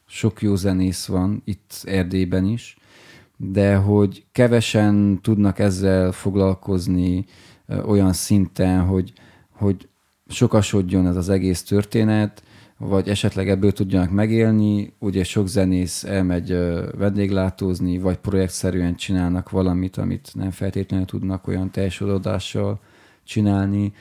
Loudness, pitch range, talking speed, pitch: -21 LUFS, 95-105 Hz, 105 wpm, 95 Hz